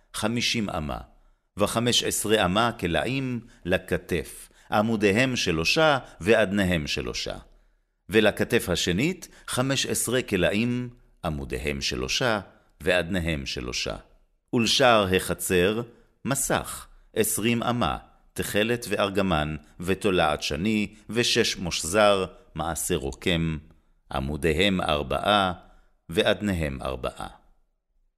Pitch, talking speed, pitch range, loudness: 100 Hz, 80 wpm, 80-115 Hz, -25 LUFS